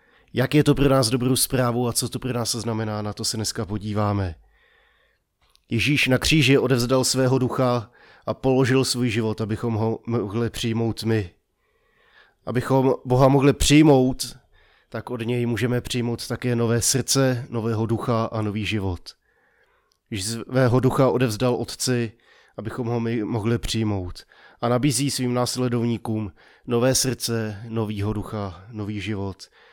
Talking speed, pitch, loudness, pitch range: 140 wpm, 120 Hz, -22 LUFS, 110-130 Hz